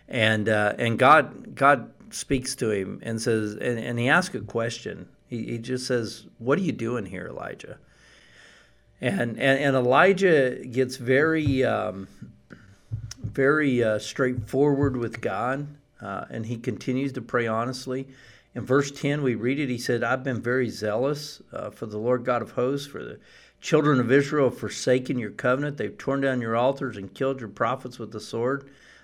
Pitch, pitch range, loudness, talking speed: 125 Hz, 115-135 Hz, -25 LUFS, 175 wpm